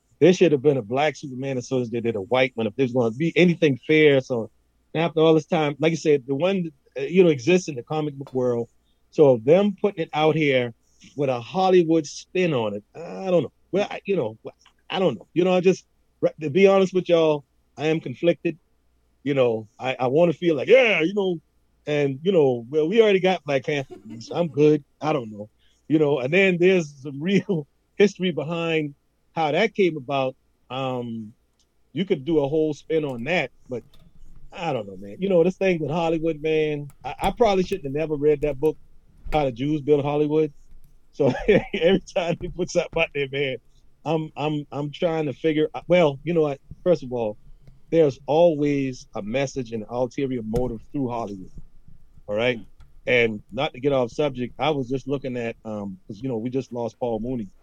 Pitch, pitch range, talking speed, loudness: 150 Hz, 130-165 Hz, 210 wpm, -23 LUFS